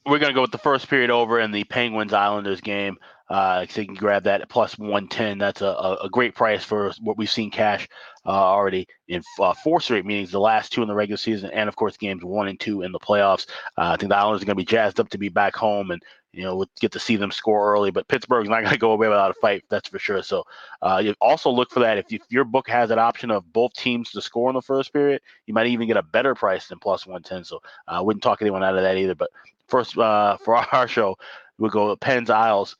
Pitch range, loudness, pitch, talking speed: 100-115 Hz, -22 LUFS, 105 Hz, 280 wpm